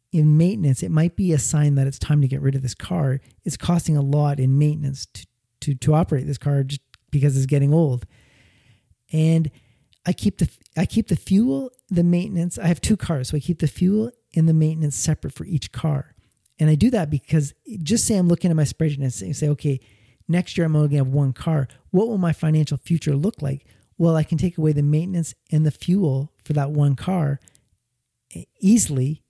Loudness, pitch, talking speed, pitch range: -21 LUFS, 150 Hz, 215 wpm, 135-170 Hz